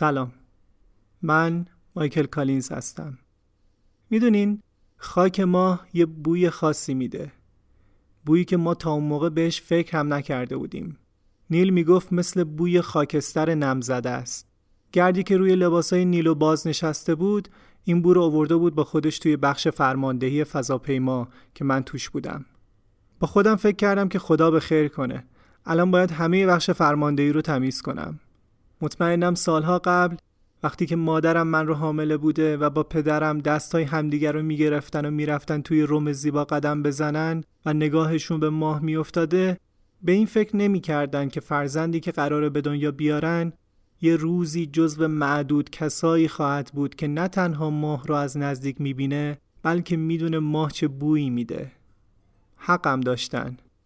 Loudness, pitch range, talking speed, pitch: -23 LUFS, 140-170 Hz, 150 wpm, 155 Hz